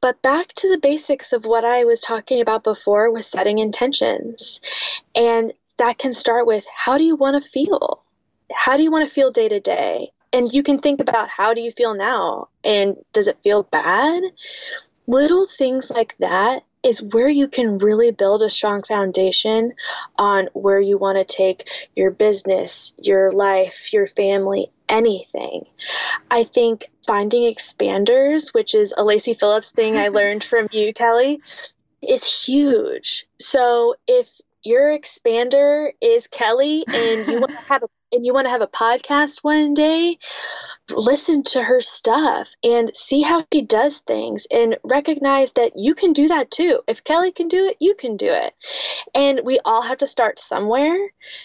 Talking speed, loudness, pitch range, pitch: 170 wpm, -18 LUFS, 225-300 Hz, 255 Hz